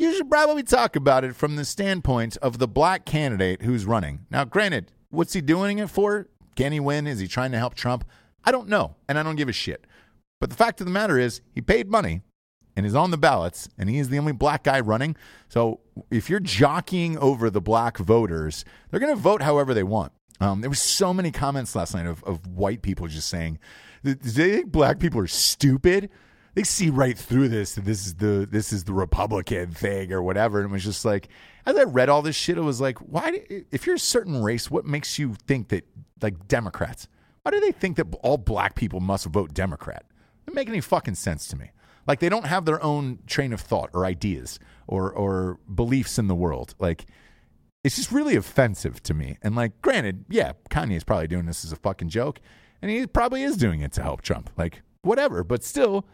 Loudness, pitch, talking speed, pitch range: -24 LUFS, 125 Hz, 225 wpm, 95-155 Hz